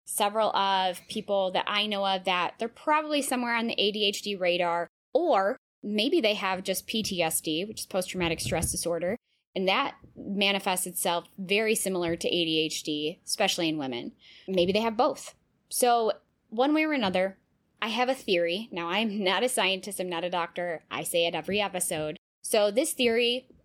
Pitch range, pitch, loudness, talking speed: 175-220 Hz, 195 Hz, -27 LUFS, 175 wpm